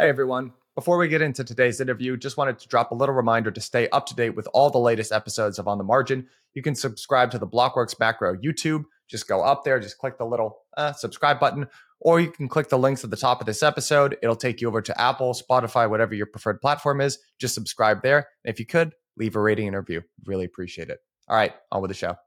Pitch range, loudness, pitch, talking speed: 110-140 Hz, -23 LUFS, 125 Hz, 250 wpm